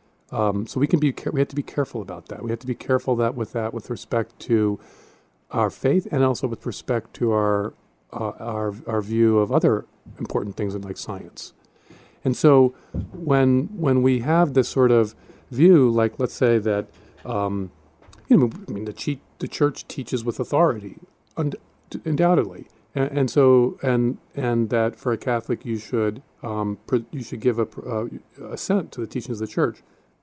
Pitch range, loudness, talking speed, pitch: 110-135 Hz, -23 LUFS, 185 wpm, 120 Hz